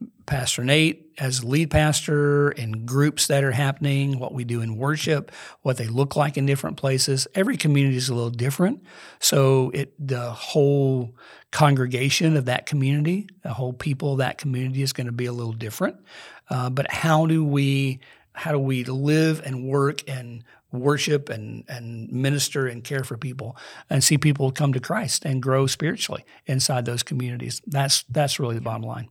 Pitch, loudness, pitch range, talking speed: 135 Hz, -23 LUFS, 125-145 Hz, 180 wpm